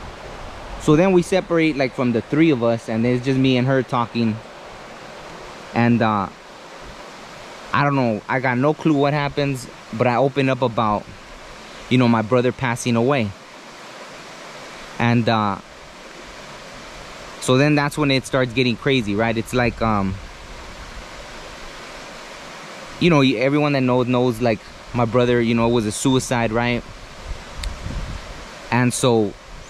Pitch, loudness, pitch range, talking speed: 125 Hz, -19 LUFS, 115-135 Hz, 145 wpm